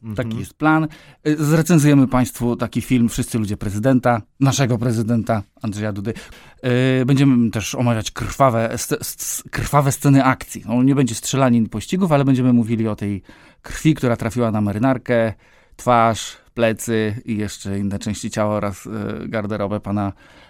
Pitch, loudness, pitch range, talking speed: 120 Hz, -19 LUFS, 110-130 Hz, 130 wpm